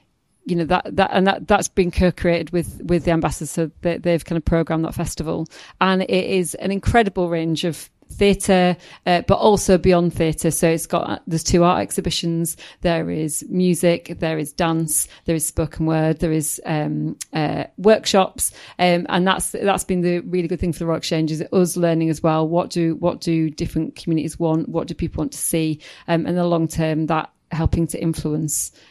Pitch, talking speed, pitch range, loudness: 170 Hz, 205 wpm, 160-180 Hz, -20 LUFS